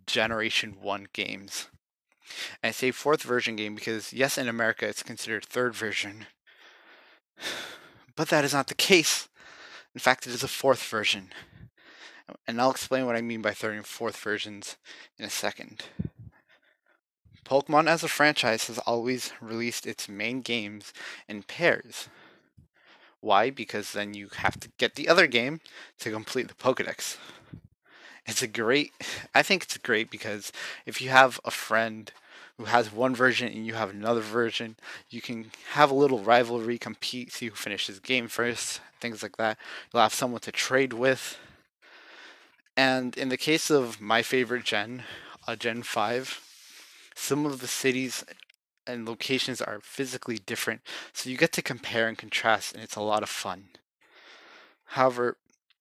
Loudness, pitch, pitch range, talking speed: -27 LUFS, 120 Hz, 110-130 Hz, 160 wpm